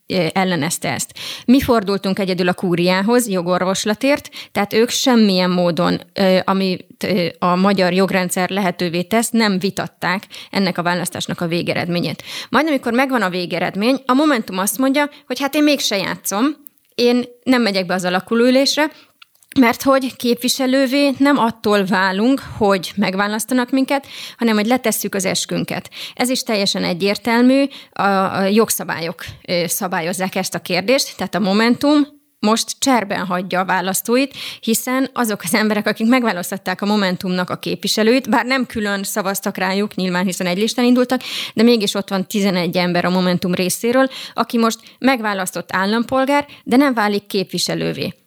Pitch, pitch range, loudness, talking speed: 205 Hz, 185-250 Hz, -17 LUFS, 145 wpm